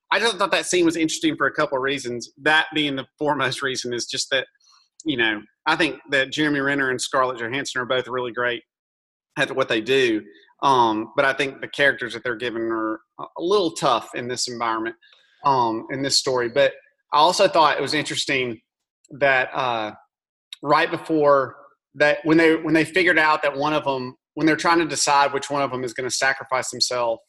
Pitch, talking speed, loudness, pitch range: 140 Hz, 205 wpm, -21 LUFS, 125-155 Hz